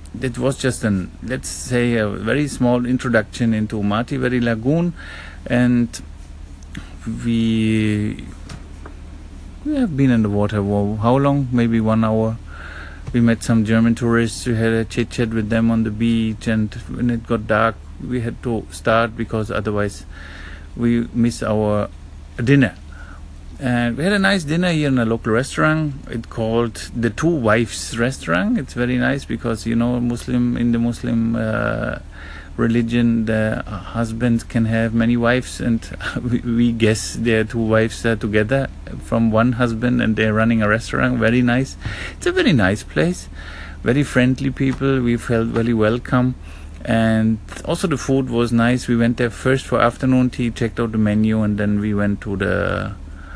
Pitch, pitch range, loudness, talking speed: 115 Hz, 105-120 Hz, -19 LUFS, 165 wpm